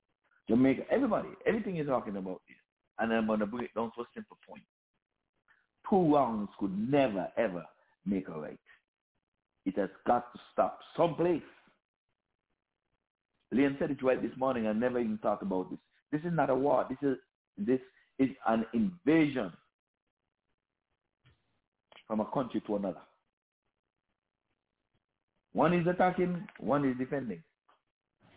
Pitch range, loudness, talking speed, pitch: 115-170 Hz, -32 LUFS, 140 wpm, 135 Hz